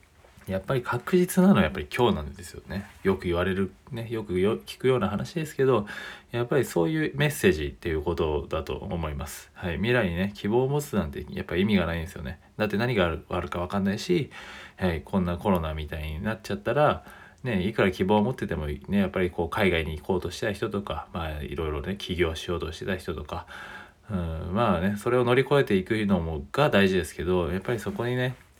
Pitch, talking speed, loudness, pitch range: 95 Hz, 445 characters per minute, -27 LUFS, 85-120 Hz